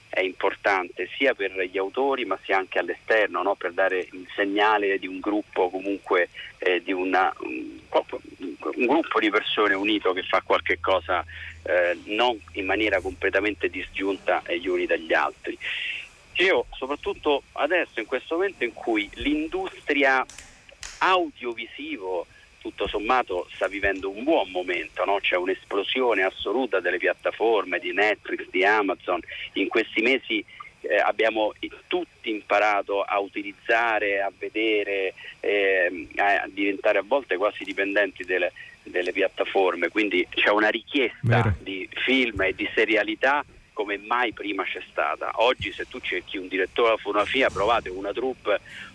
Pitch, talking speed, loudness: 310 Hz, 140 wpm, -24 LUFS